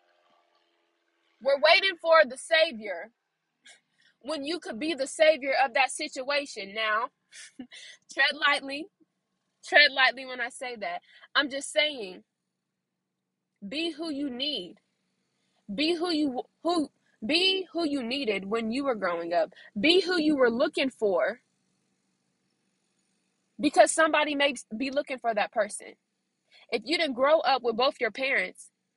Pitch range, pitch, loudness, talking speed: 245-320 Hz, 285 Hz, -26 LUFS, 135 wpm